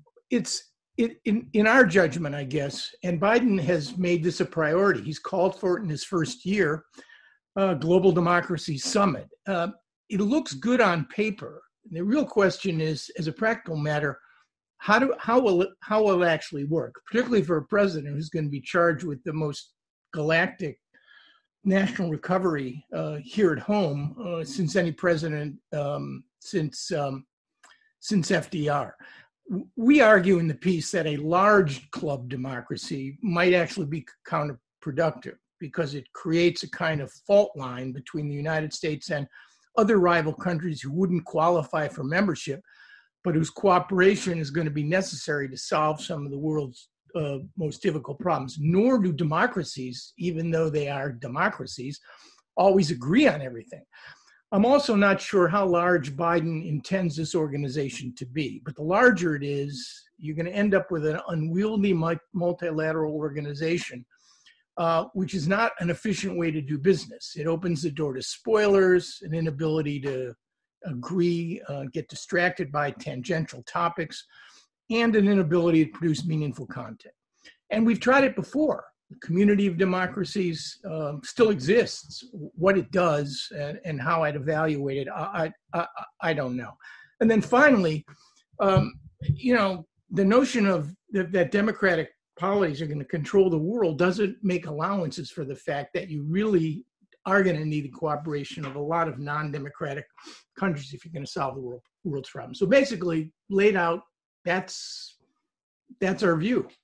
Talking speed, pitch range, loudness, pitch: 160 wpm, 150-195 Hz, -25 LUFS, 170 Hz